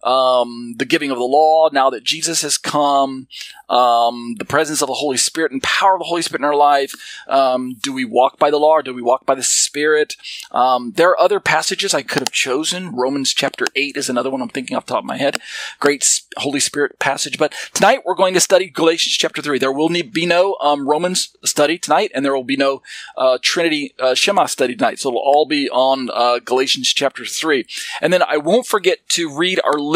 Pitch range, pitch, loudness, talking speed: 135-170 Hz, 145 Hz, -16 LUFS, 225 wpm